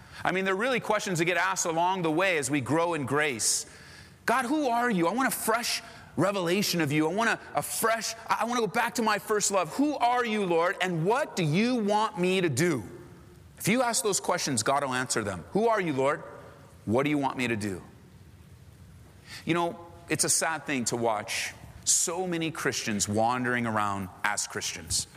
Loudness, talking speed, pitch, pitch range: -27 LUFS, 210 wpm, 175 Hz, 135-215 Hz